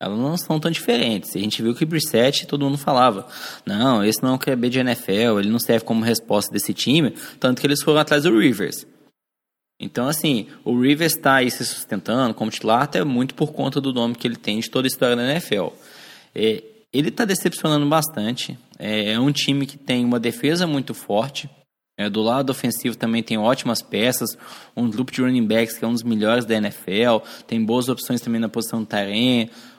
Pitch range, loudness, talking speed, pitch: 115-145 Hz, -20 LUFS, 210 wpm, 125 Hz